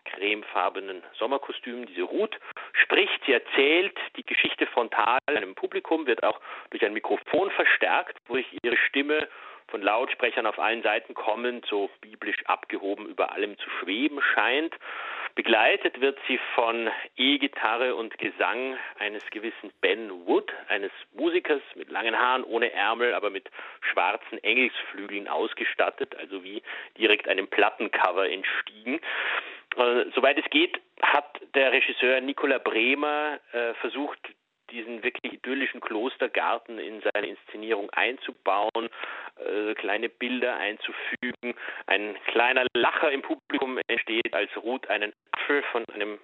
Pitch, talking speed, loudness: 305 Hz, 125 wpm, -26 LUFS